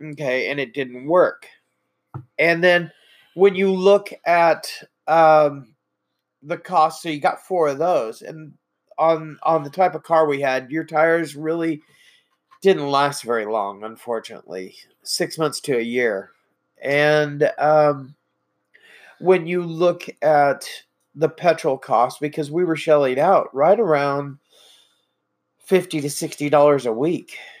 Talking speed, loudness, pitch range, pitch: 140 wpm, -19 LUFS, 145-165 Hz, 155 Hz